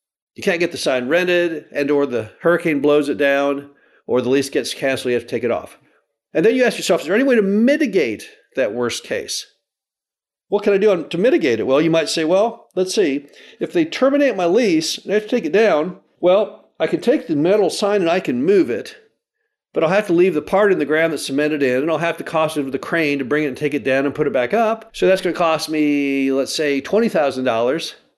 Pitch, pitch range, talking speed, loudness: 170 Hz, 145-220 Hz, 255 wpm, -18 LUFS